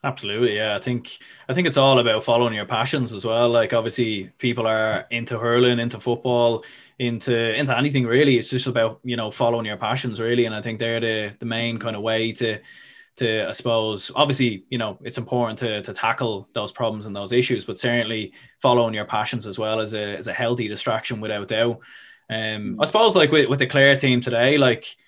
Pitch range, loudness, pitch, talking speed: 110-125 Hz, -21 LUFS, 115 Hz, 210 wpm